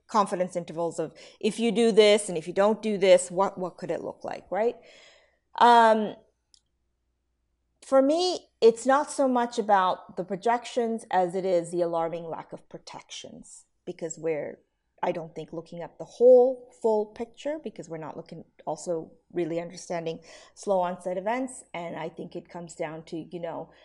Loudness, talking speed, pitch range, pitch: -26 LUFS, 170 wpm, 165-225 Hz, 180 Hz